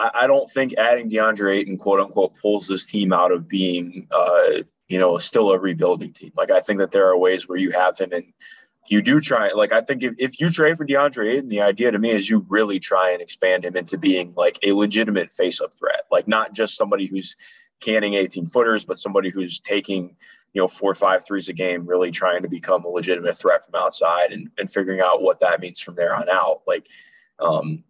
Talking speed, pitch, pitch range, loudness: 230 wpm, 100 Hz, 95-135 Hz, -20 LUFS